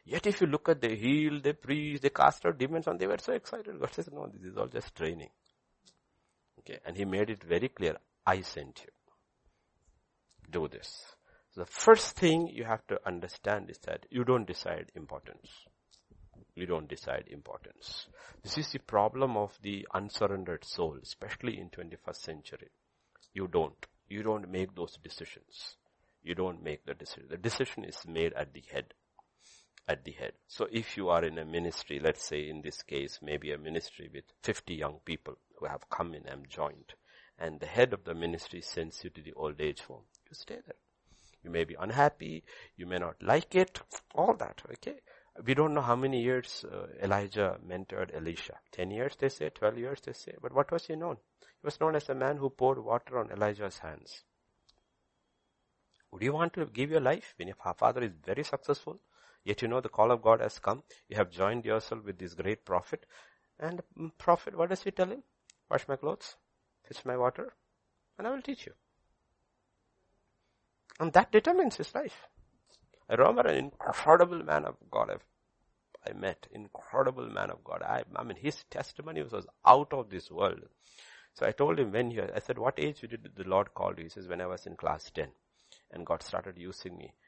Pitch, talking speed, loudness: 115 Hz, 195 wpm, -32 LUFS